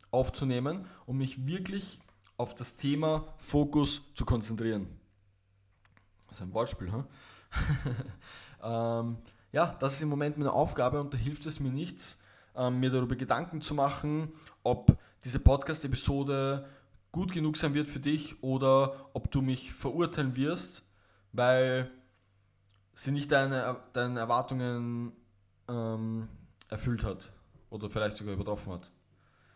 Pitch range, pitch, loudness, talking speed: 105-140 Hz, 125 Hz, -32 LUFS, 130 wpm